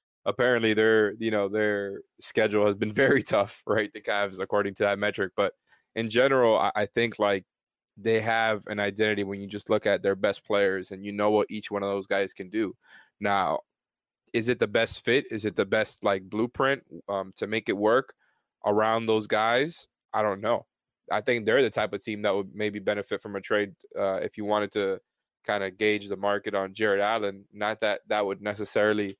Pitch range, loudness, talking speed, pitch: 100-110 Hz, -27 LUFS, 210 wpm, 105 Hz